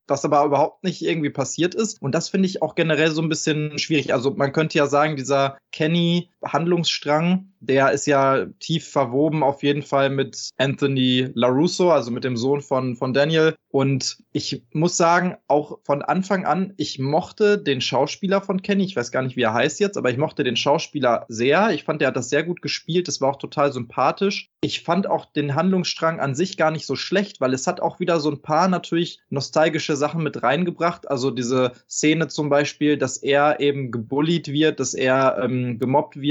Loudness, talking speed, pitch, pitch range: -21 LUFS, 205 wpm, 150 Hz, 135-170 Hz